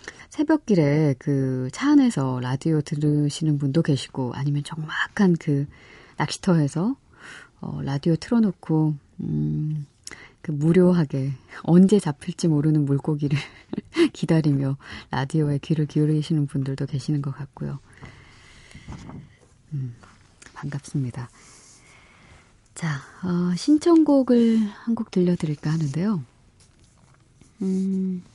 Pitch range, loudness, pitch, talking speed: 135-180 Hz, -23 LUFS, 150 Hz, 230 characters per minute